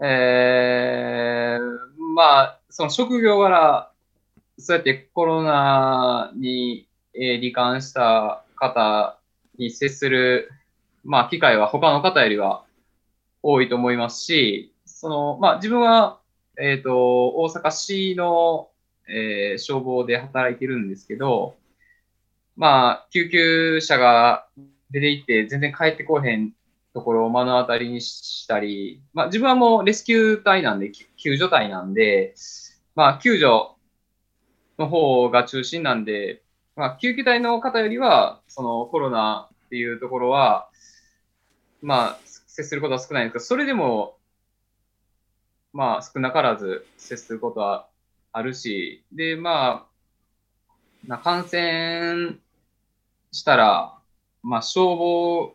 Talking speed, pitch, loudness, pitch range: 230 characters per minute, 135 Hz, -20 LUFS, 120-170 Hz